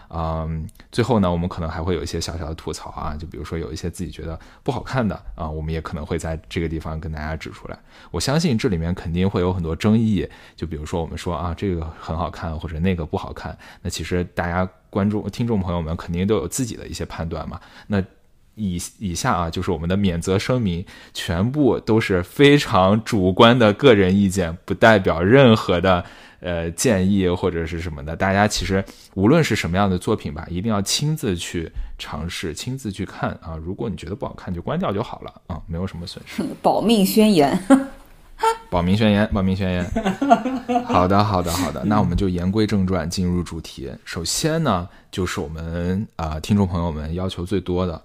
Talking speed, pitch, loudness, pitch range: 310 characters per minute, 90 Hz, -21 LUFS, 85-105 Hz